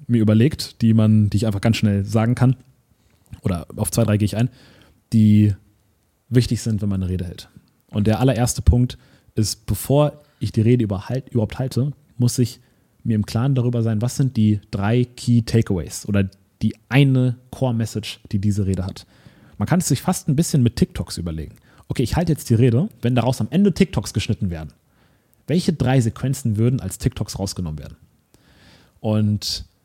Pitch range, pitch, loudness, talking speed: 105-125 Hz, 115 Hz, -20 LUFS, 180 wpm